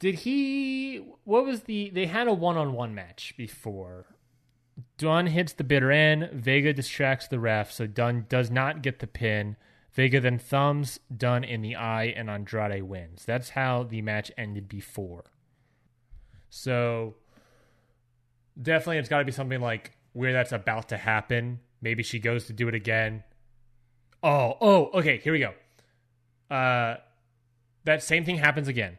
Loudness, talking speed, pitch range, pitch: -27 LUFS, 155 wpm, 115-140 Hz, 120 Hz